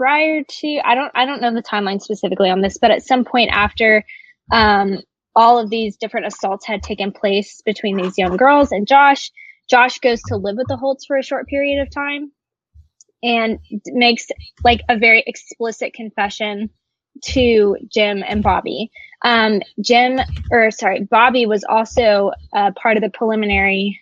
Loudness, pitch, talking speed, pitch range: -16 LUFS, 225 Hz, 170 wpm, 205-250 Hz